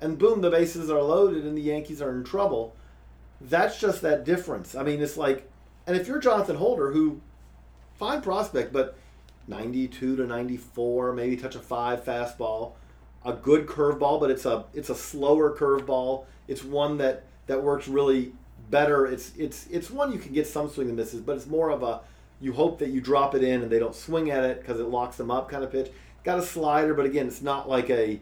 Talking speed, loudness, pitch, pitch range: 215 wpm, -26 LUFS, 135 Hz, 120-150 Hz